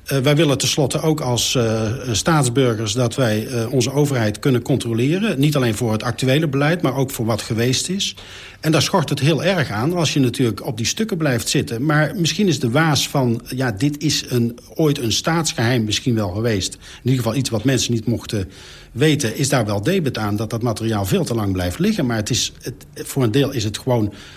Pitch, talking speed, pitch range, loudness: 125 Hz, 220 wpm, 115-150 Hz, -19 LUFS